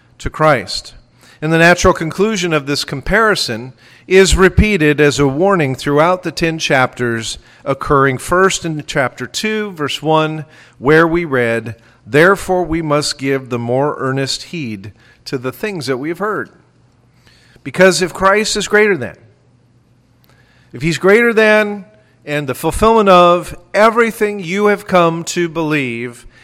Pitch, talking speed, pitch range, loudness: 155 Hz, 145 wpm, 125-185 Hz, -14 LUFS